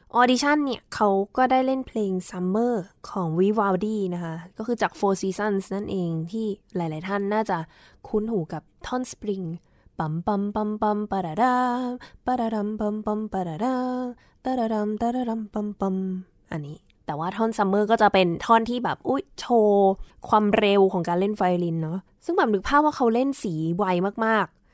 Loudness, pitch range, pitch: -24 LUFS, 185-230 Hz, 210 Hz